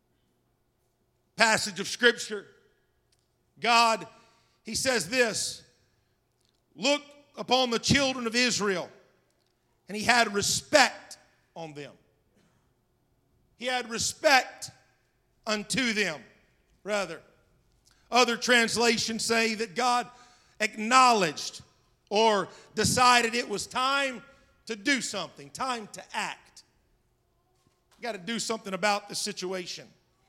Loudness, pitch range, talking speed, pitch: -26 LUFS, 160-240 Hz, 100 wpm, 215 Hz